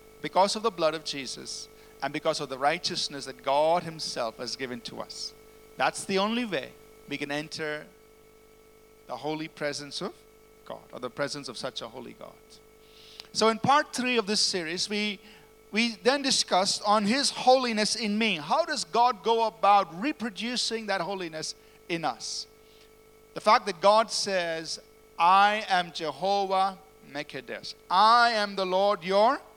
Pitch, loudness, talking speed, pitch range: 210 Hz, -27 LUFS, 160 wpm, 170-220 Hz